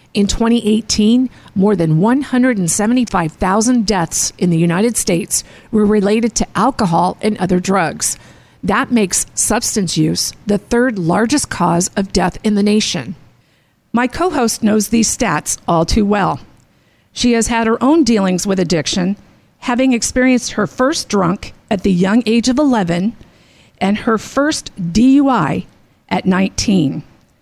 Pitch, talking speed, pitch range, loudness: 215 Hz, 140 wpm, 185-240 Hz, -15 LUFS